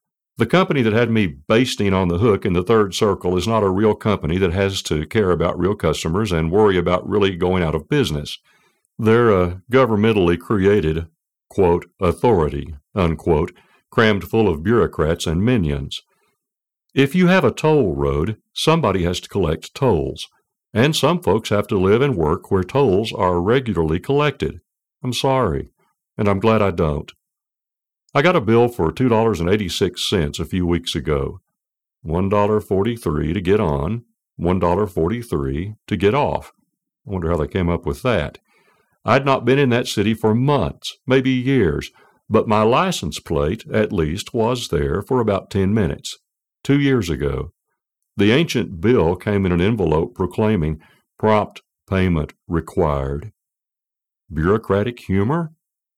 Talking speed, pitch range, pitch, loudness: 160 wpm, 85-115 Hz, 100 Hz, -19 LUFS